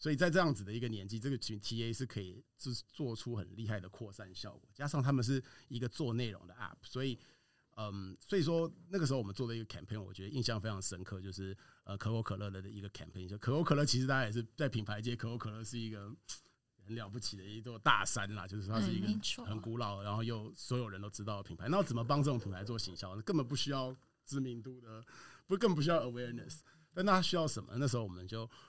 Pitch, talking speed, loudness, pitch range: 115 Hz, 405 characters per minute, -38 LUFS, 105-135 Hz